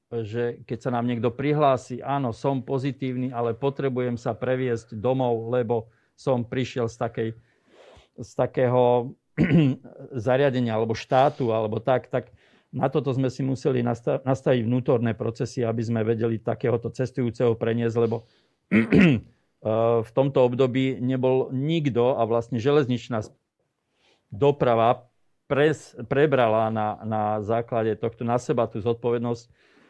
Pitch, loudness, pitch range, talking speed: 120 Hz, -24 LUFS, 115-130 Hz, 120 wpm